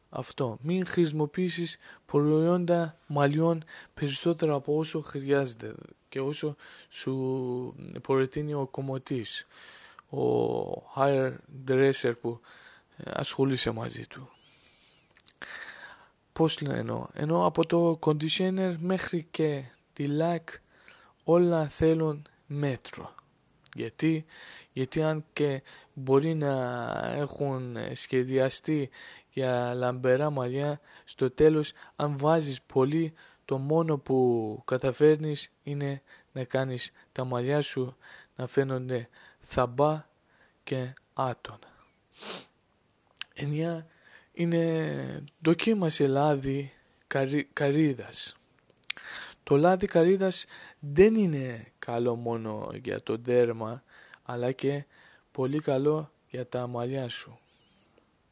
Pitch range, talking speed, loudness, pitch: 130-160 Hz, 95 wpm, -29 LUFS, 145 Hz